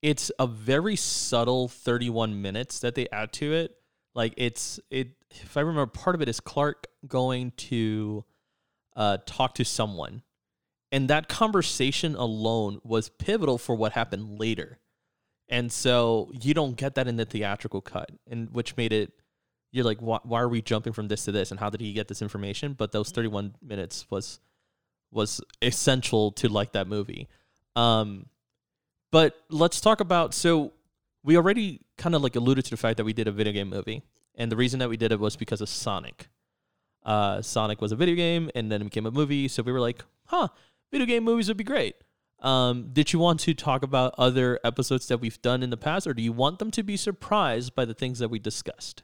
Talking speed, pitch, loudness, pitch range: 205 wpm, 120 Hz, -27 LUFS, 110-145 Hz